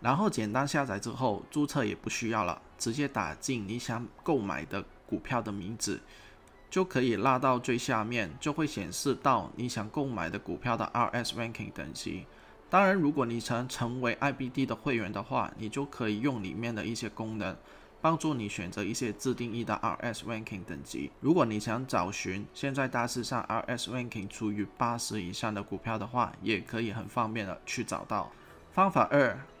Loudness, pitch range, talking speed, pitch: -32 LUFS, 105-125 Hz, 315 characters per minute, 115 Hz